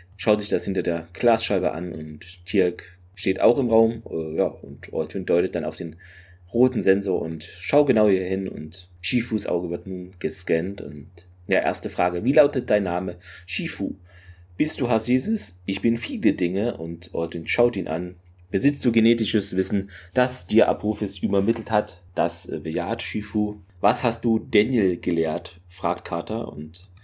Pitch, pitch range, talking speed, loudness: 95 Hz, 85-110 Hz, 165 wpm, -23 LUFS